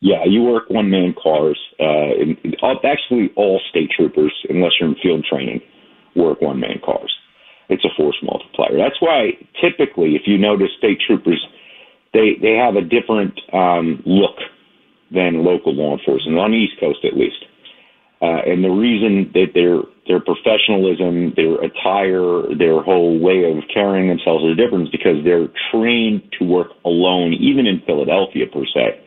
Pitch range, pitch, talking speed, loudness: 85-105 Hz, 90 Hz, 165 wpm, -16 LUFS